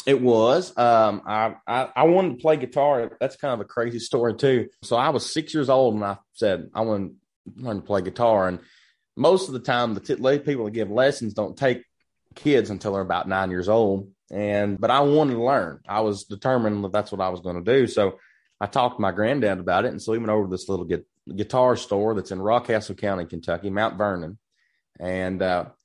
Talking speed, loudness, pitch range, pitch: 225 wpm, -23 LUFS, 100-125 Hz, 110 Hz